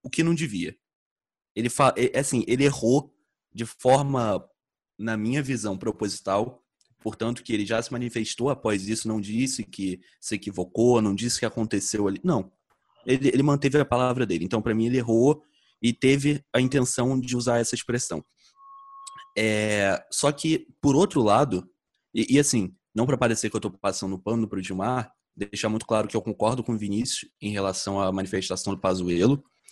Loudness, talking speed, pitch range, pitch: -25 LUFS, 175 wpm, 105-130 Hz, 115 Hz